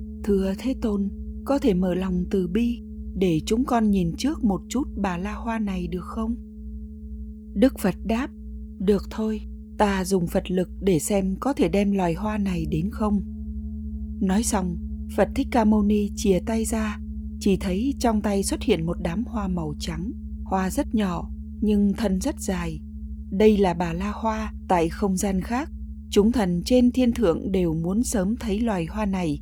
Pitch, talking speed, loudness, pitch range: 195 Hz, 185 wpm, -24 LUFS, 165-220 Hz